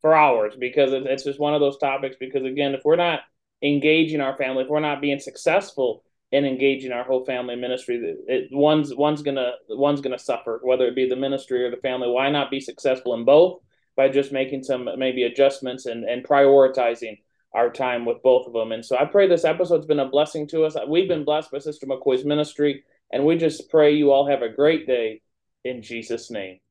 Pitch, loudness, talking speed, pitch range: 135 Hz, -21 LUFS, 215 wpm, 125-150 Hz